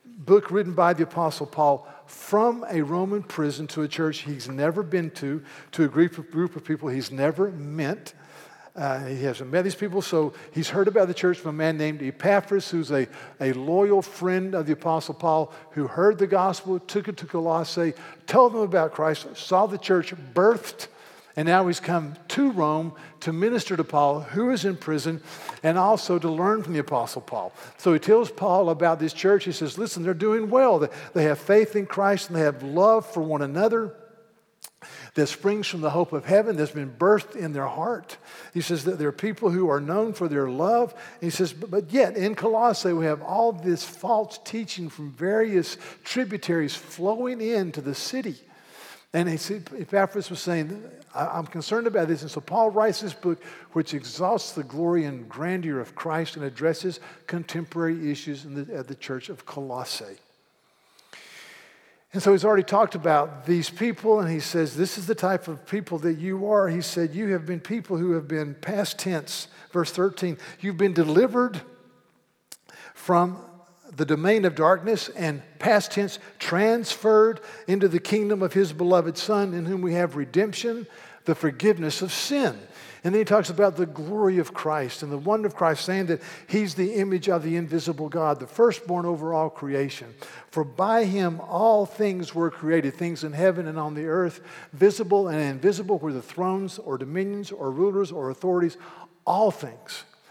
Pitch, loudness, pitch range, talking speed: 175 Hz, -25 LUFS, 155-200 Hz, 185 wpm